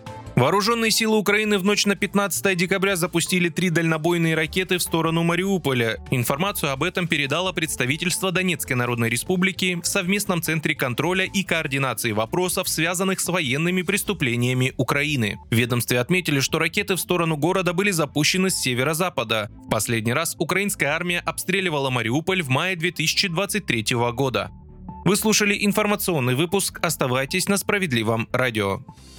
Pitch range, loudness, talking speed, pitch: 135-190 Hz, -21 LUFS, 135 wpm, 170 Hz